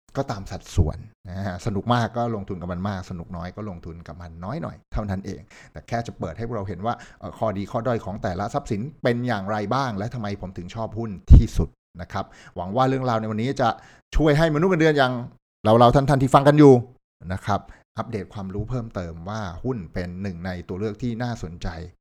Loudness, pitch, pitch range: -23 LUFS, 105 Hz, 90-120 Hz